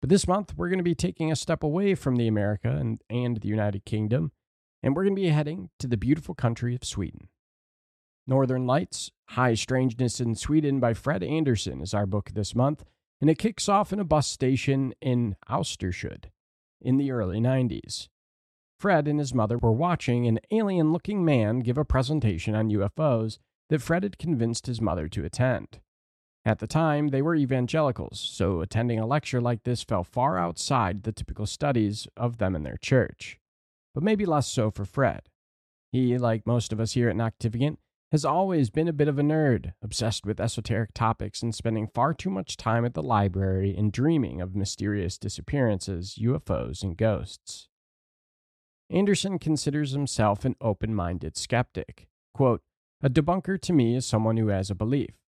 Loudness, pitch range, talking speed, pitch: -27 LUFS, 105-145 Hz, 180 wpm, 120 Hz